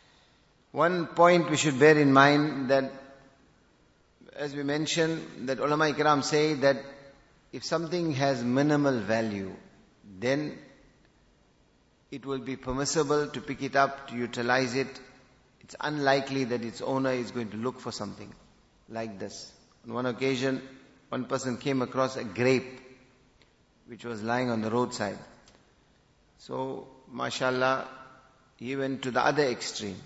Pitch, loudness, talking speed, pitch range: 130 Hz, -28 LUFS, 140 wpm, 125-140 Hz